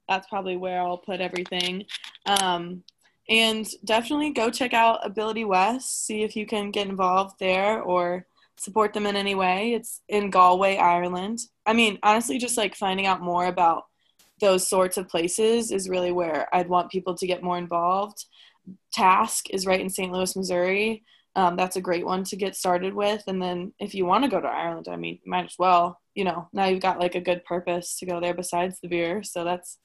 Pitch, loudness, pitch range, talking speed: 185 Hz, -24 LUFS, 180-205 Hz, 205 wpm